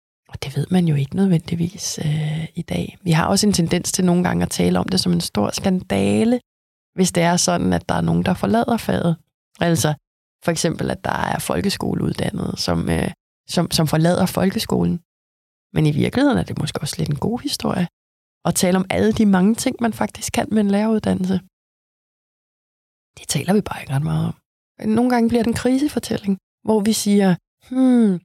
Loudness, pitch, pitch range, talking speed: -20 LUFS, 175 Hz, 150-205 Hz, 195 wpm